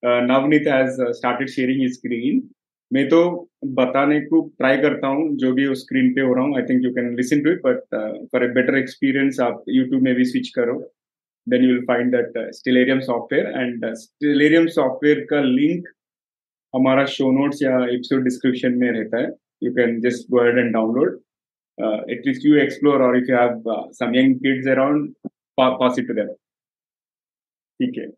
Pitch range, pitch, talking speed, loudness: 125-150 Hz, 130 Hz, 165 wpm, -19 LUFS